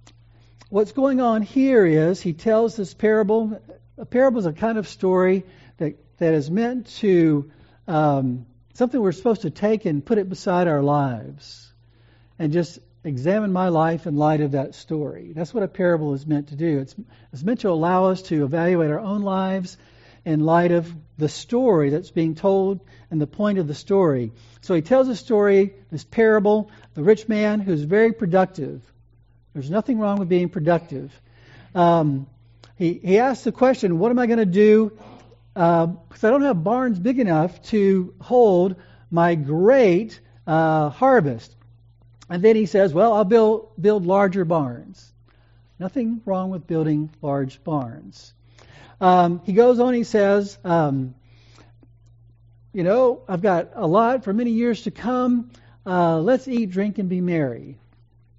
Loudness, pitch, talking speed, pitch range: -20 LUFS, 170 Hz, 165 wpm, 135-210 Hz